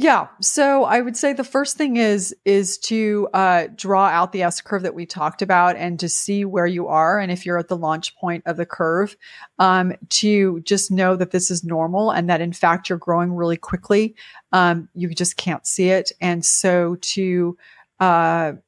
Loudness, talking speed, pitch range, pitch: -19 LUFS, 200 wpm, 175-200 Hz, 180 Hz